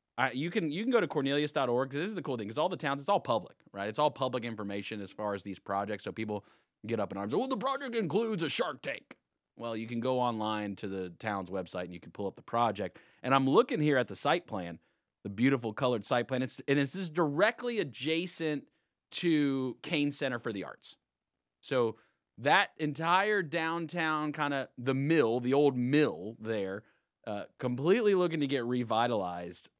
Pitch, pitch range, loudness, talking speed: 130 Hz, 105-155 Hz, -32 LUFS, 205 wpm